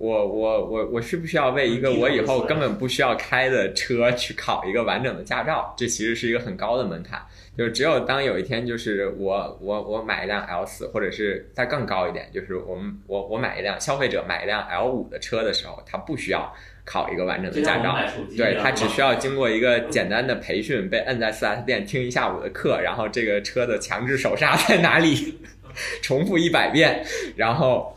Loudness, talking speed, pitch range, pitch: -23 LUFS, 320 characters per minute, 105-155 Hz, 120 Hz